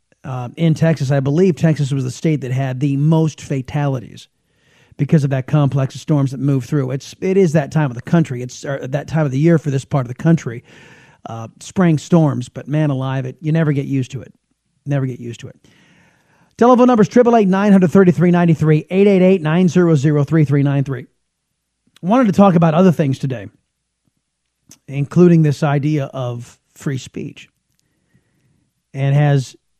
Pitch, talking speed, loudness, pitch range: 145 Hz, 195 wpm, -15 LUFS, 135-165 Hz